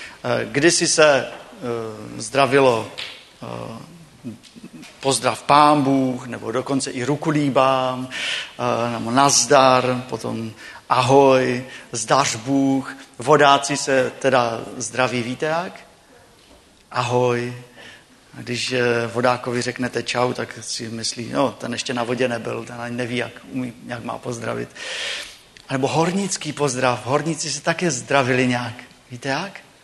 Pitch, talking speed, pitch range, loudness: 125 Hz, 115 wpm, 120-140 Hz, -20 LUFS